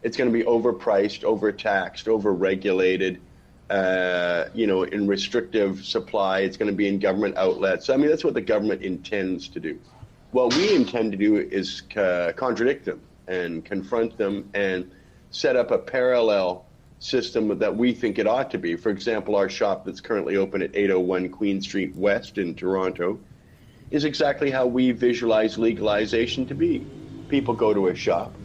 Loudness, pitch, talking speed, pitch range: -23 LUFS, 100 Hz, 175 wpm, 95-115 Hz